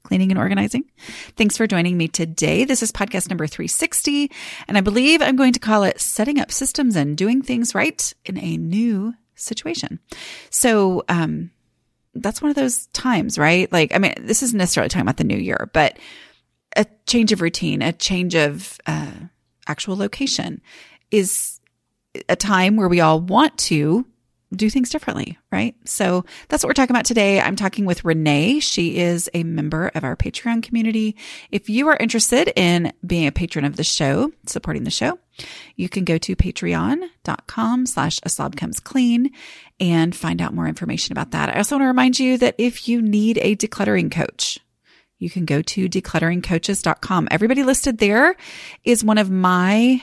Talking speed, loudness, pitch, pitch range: 175 wpm, -19 LUFS, 210 Hz, 170-250 Hz